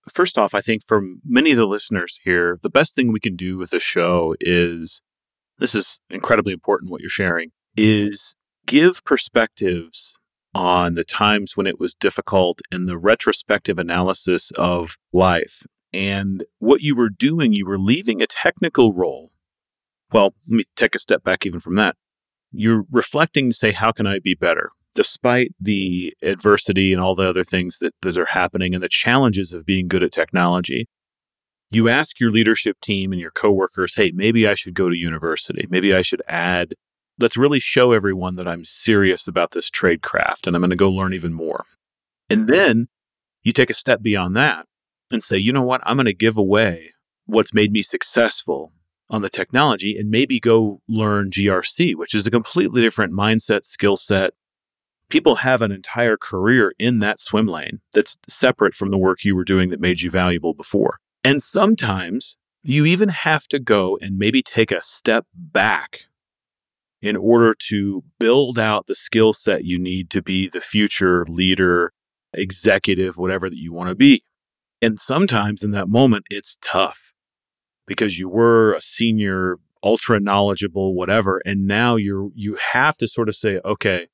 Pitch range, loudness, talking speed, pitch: 95-115 Hz, -18 LUFS, 180 wpm, 100 Hz